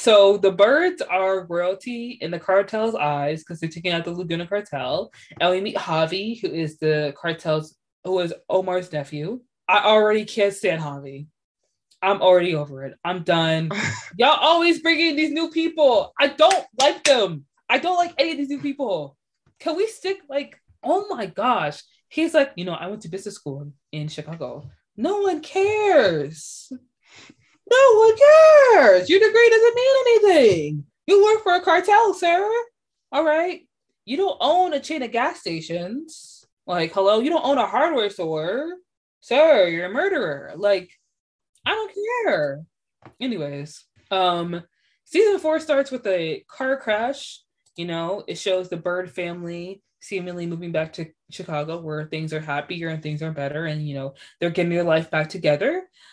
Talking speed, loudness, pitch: 165 wpm, -20 LUFS, 200 Hz